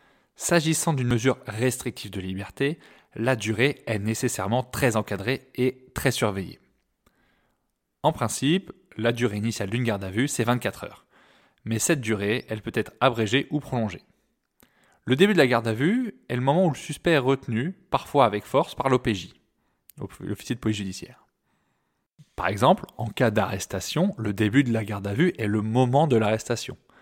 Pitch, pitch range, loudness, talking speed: 120 Hz, 105-135 Hz, -25 LUFS, 170 wpm